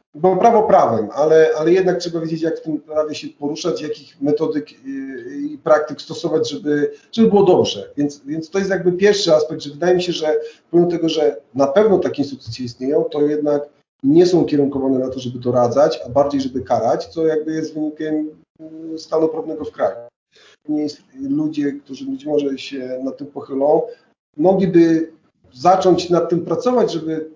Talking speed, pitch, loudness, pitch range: 170 wpm, 155 Hz, -18 LUFS, 145-175 Hz